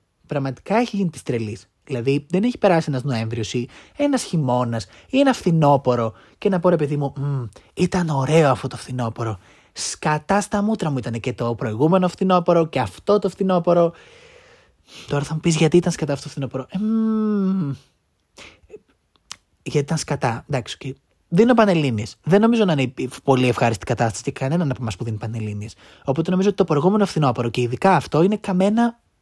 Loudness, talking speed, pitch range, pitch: -20 LUFS, 170 wpm, 125-190 Hz, 150 Hz